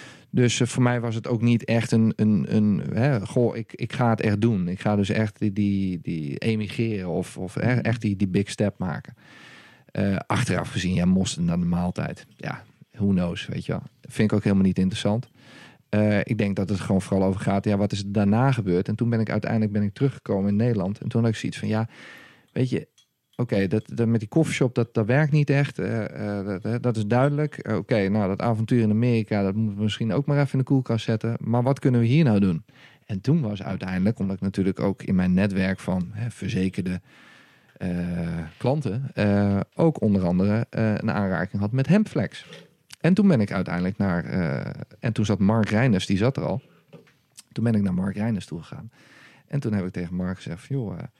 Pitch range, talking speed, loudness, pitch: 100-120 Hz, 225 wpm, -24 LUFS, 110 Hz